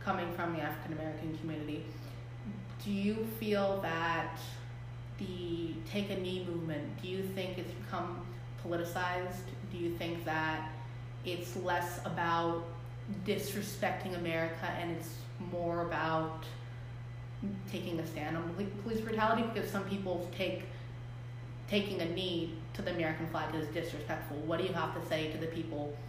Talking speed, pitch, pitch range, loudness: 140 wpm, 155 Hz, 120-170 Hz, -37 LUFS